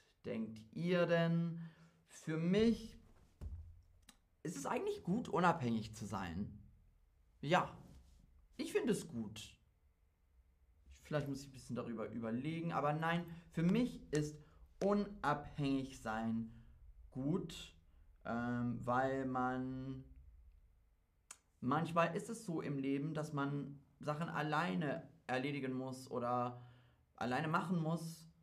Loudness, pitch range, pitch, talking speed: -40 LUFS, 105-165 Hz, 130 Hz, 110 wpm